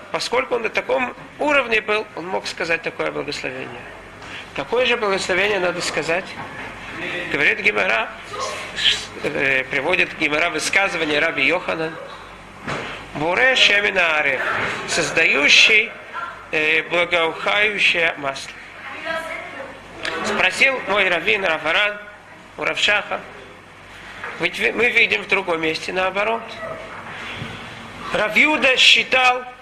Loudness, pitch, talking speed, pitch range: -18 LUFS, 205 Hz, 90 wpm, 175-250 Hz